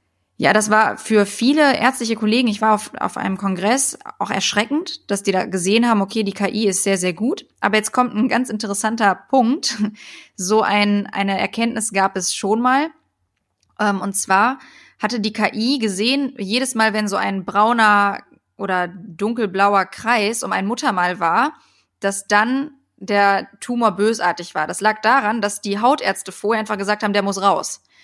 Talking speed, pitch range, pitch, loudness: 170 wpm, 195-235 Hz, 210 Hz, -18 LUFS